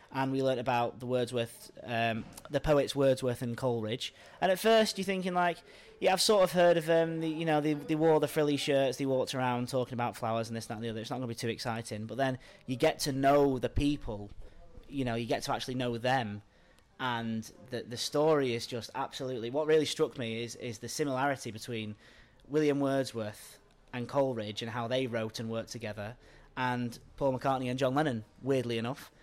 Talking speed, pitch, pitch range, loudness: 215 wpm, 125 Hz, 115-140 Hz, -32 LUFS